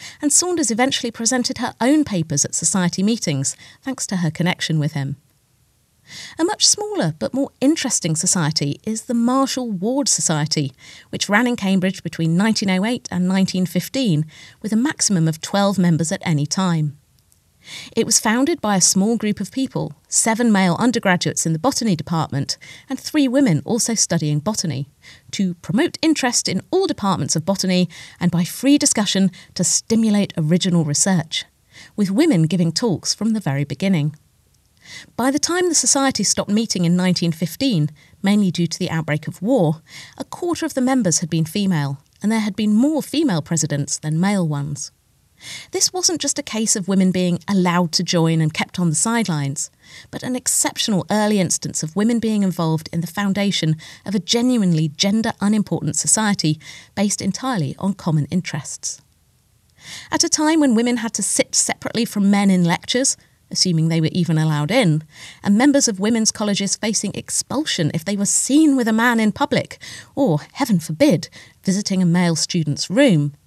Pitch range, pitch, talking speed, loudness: 160-235 Hz, 190 Hz, 170 wpm, -19 LUFS